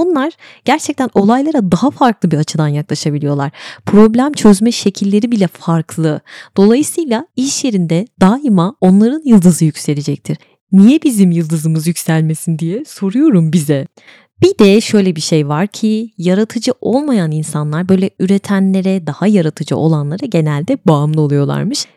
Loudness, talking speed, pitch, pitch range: -13 LUFS, 125 wpm, 190 Hz, 160-230 Hz